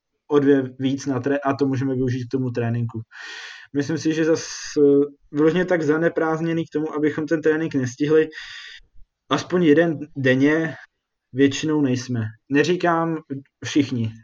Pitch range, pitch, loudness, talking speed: 130-155 Hz, 145 Hz, -21 LUFS, 135 wpm